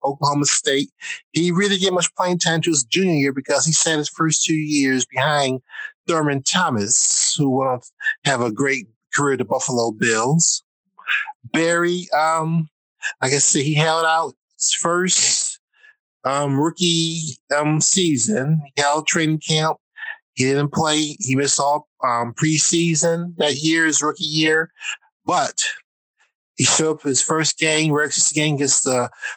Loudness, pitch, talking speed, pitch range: -18 LUFS, 155 Hz, 155 wpm, 140-170 Hz